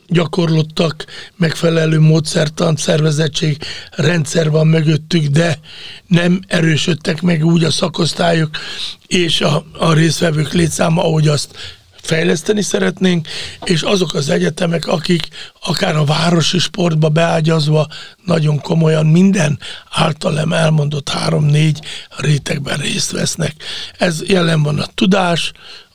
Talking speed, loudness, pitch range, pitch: 110 wpm, -15 LUFS, 155-175 Hz, 165 Hz